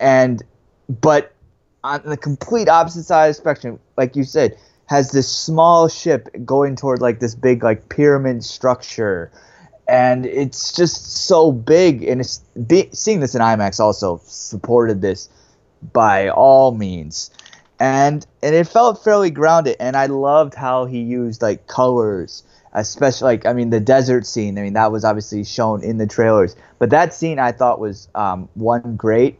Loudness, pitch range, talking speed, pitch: -16 LUFS, 115-145 Hz, 165 wpm, 125 Hz